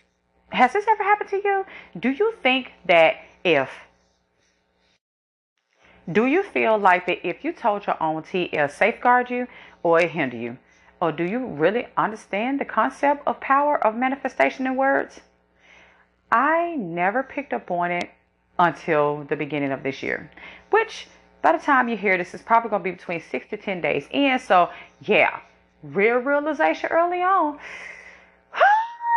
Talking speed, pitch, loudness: 160 wpm, 205 Hz, -22 LUFS